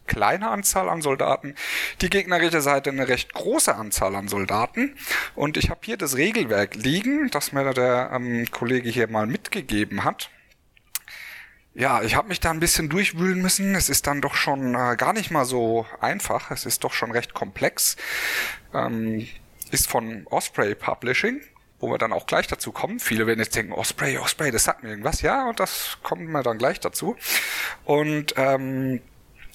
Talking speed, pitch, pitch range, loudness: 180 wpm, 135 Hz, 115-170 Hz, -23 LUFS